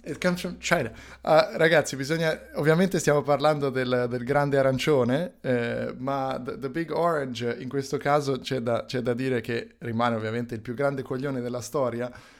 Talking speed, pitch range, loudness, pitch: 160 wpm, 125-150 Hz, -26 LUFS, 135 Hz